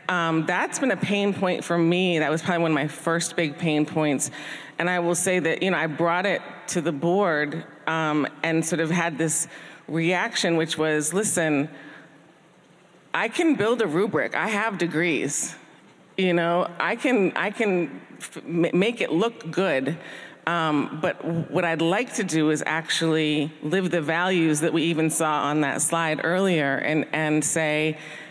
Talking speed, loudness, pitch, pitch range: 175 wpm, -24 LUFS, 165 Hz, 155-180 Hz